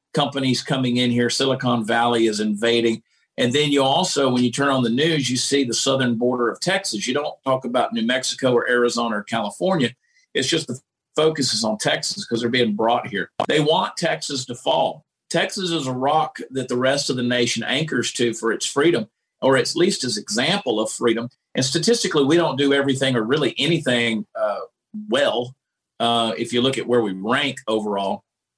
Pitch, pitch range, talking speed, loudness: 125 Hz, 120-140 Hz, 195 wpm, -20 LUFS